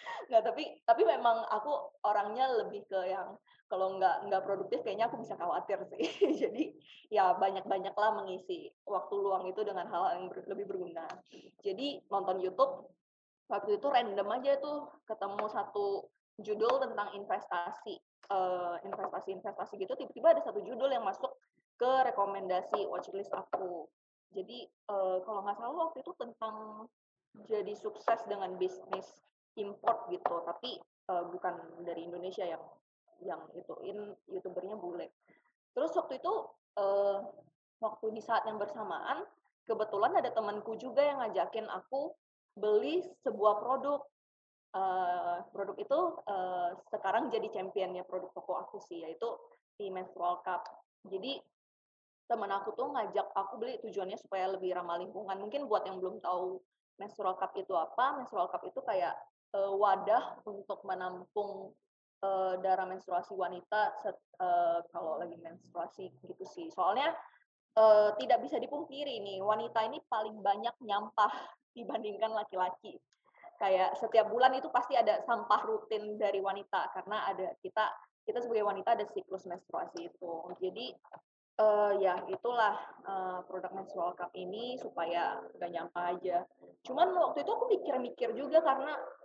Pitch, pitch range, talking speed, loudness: 205 Hz, 185-250 Hz, 140 wpm, -35 LUFS